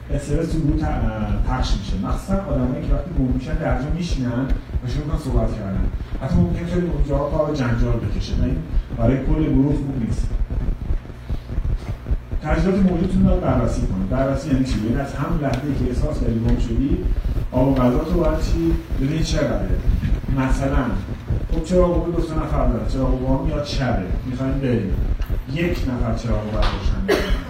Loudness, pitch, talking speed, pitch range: -22 LUFS, 130 Hz, 160 wpm, 110-145 Hz